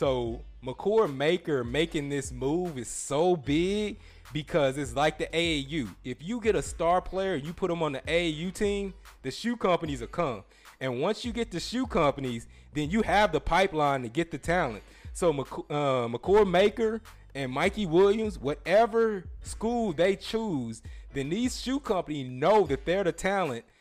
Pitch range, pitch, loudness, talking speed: 135-200 Hz, 170 Hz, -28 LUFS, 175 wpm